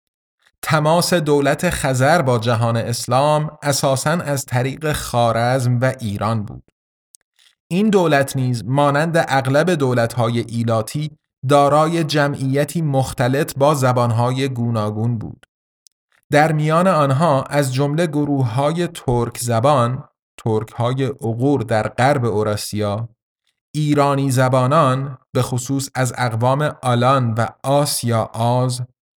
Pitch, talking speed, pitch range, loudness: 135 Hz, 105 wpm, 120-145 Hz, -18 LUFS